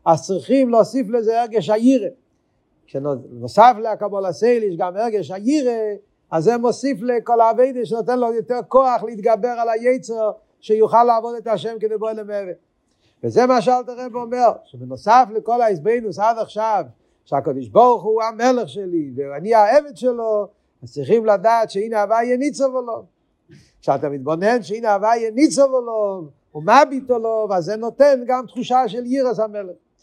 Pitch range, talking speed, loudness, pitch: 205-245 Hz, 145 wpm, -18 LUFS, 225 Hz